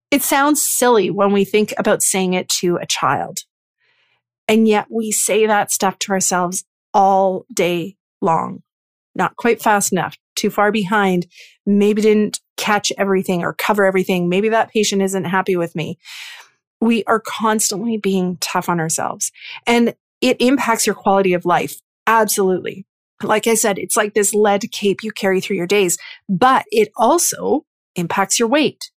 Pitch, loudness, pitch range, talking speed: 205 Hz, -17 LUFS, 190-220 Hz, 160 wpm